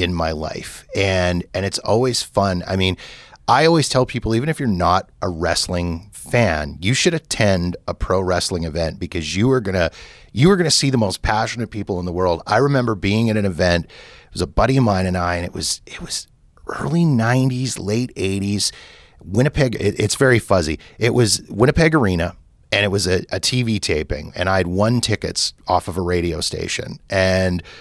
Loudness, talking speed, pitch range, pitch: -19 LUFS, 200 wpm, 90-120 Hz, 100 Hz